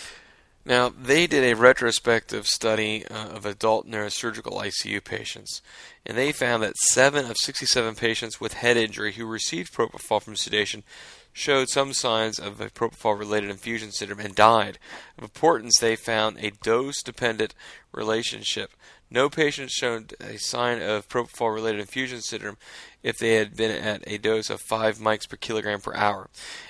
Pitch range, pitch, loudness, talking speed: 105-120 Hz, 110 Hz, -24 LUFS, 160 wpm